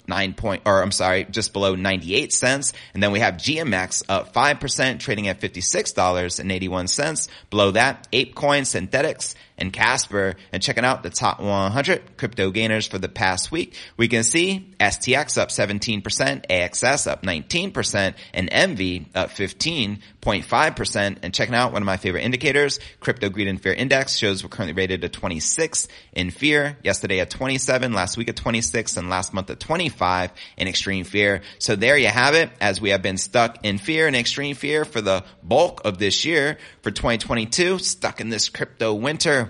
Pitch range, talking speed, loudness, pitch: 95-130 Hz, 175 wpm, -21 LUFS, 105 Hz